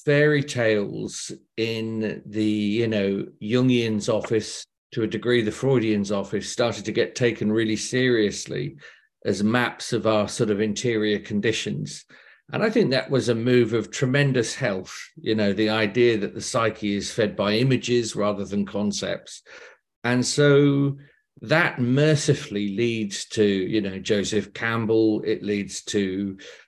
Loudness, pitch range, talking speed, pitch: -23 LUFS, 105-125 Hz, 145 wpm, 110 Hz